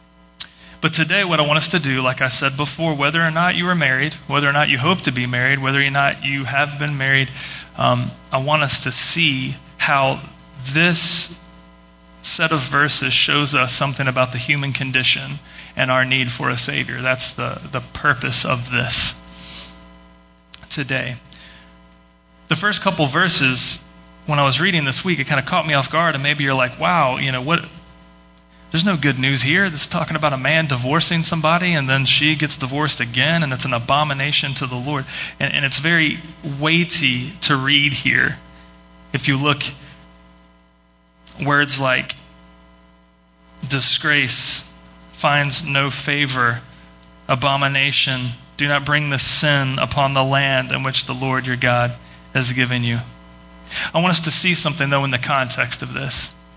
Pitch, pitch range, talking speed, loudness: 135 Hz, 120-150 Hz, 170 wpm, -17 LUFS